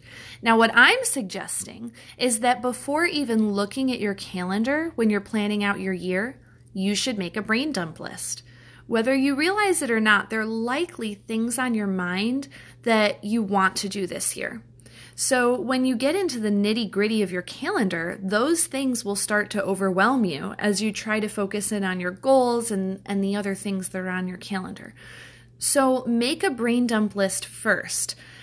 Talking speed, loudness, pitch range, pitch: 190 wpm, -23 LUFS, 190-245 Hz, 210 Hz